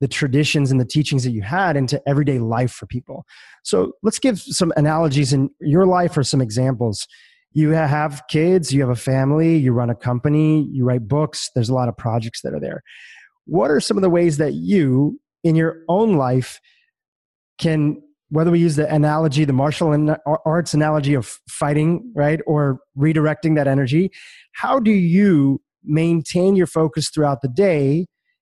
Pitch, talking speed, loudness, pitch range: 150 Hz, 175 wpm, -18 LUFS, 135-170 Hz